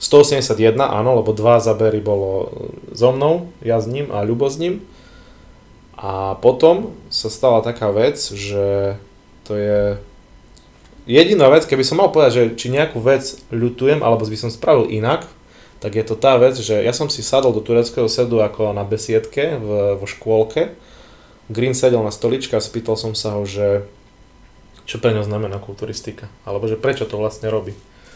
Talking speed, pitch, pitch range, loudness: 170 wpm, 110 Hz, 105-125 Hz, -17 LUFS